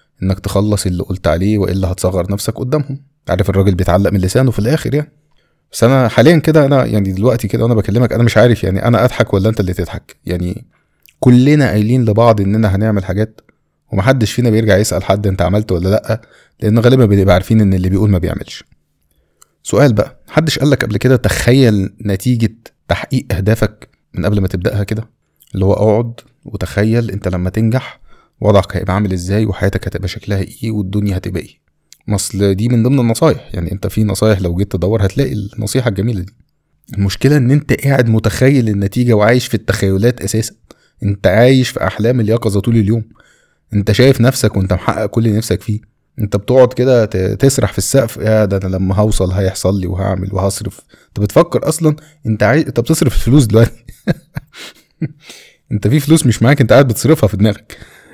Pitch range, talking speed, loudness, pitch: 100-125 Hz, 175 wpm, -13 LUFS, 110 Hz